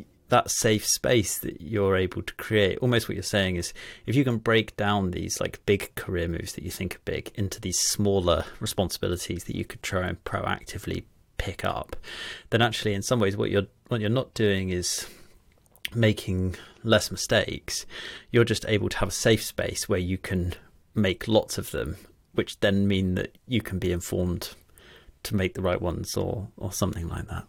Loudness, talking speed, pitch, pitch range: -27 LUFS, 190 wpm, 100 Hz, 90-110 Hz